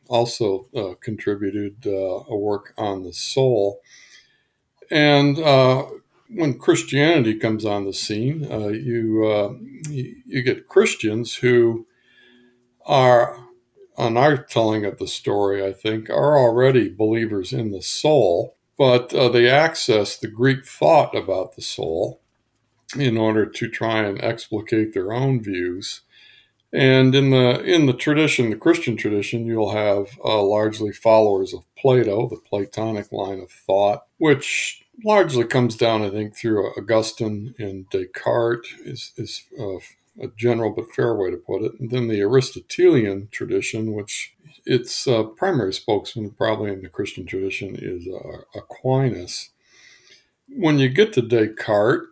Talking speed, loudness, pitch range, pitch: 140 wpm, -20 LUFS, 105-130 Hz, 115 Hz